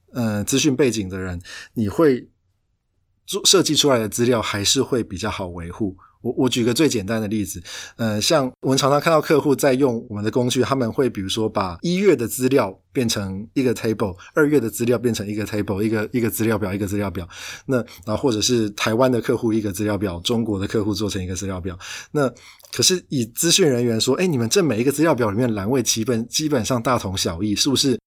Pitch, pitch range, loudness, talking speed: 110 Hz, 105-130 Hz, -20 LUFS, 345 characters per minute